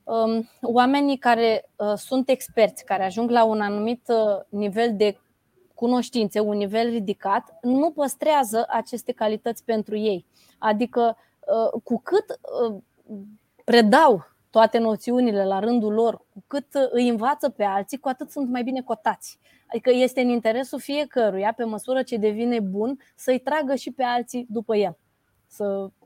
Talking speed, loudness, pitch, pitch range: 140 wpm, -23 LUFS, 235 Hz, 215-255 Hz